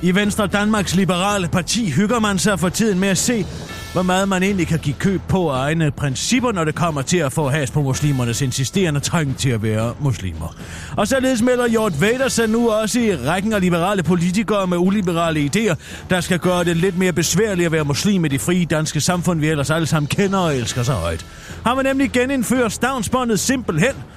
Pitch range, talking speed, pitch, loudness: 150-210 Hz, 210 wpm, 180 Hz, -18 LUFS